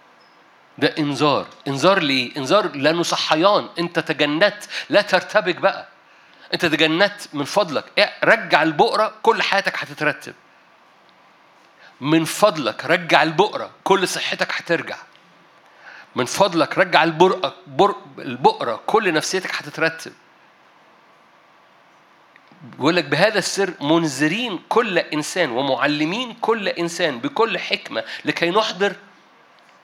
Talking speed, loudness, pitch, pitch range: 100 wpm, -19 LUFS, 170 Hz, 150-195 Hz